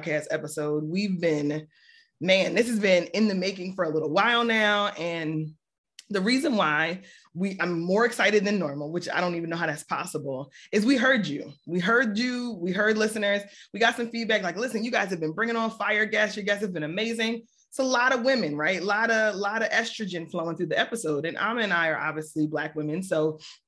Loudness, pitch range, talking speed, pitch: -26 LUFS, 165-225 Hz, 220 wpm, 195 Hz